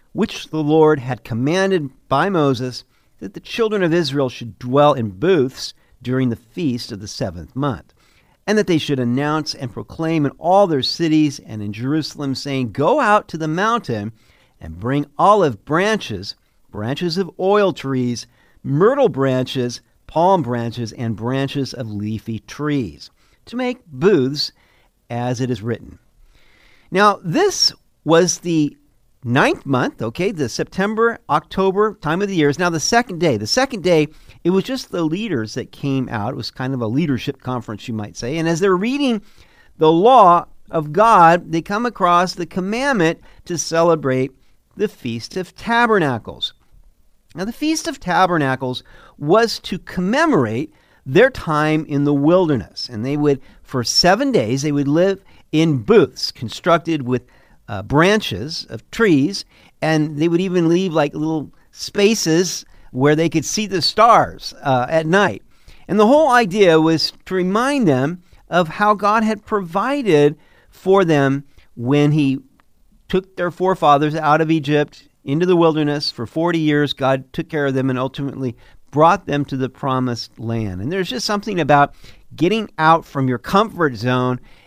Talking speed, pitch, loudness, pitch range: 160 wpm, 150 Hz, -18 LUFS, 130-180 Hz